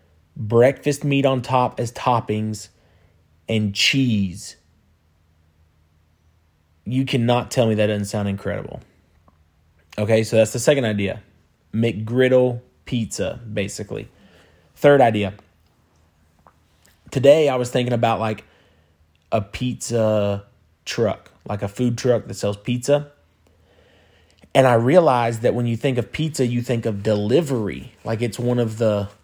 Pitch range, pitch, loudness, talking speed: 85-120 Hz, 105 Hz, -20 LUFS, 125 wpm